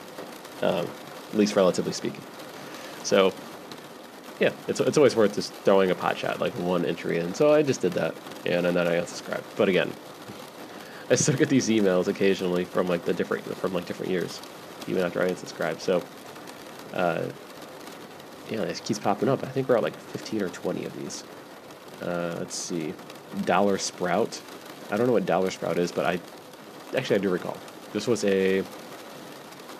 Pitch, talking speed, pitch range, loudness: 95 Hz, 175 wpm, 90-105 Hz, -26 LUFS